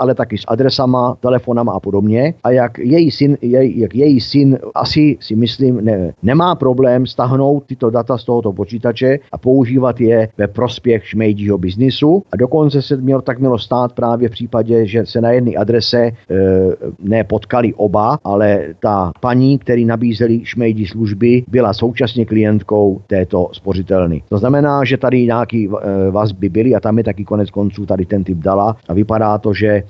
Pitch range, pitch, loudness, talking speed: 105-125 Hz, 115 Hz, -14 LUFS, 175 wpm